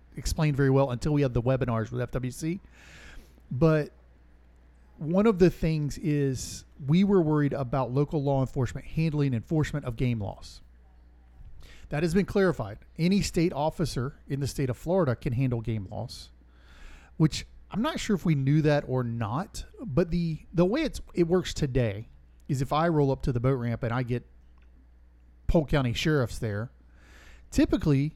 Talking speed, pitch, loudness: 170 wpm, 130 Hz, -28 LUFS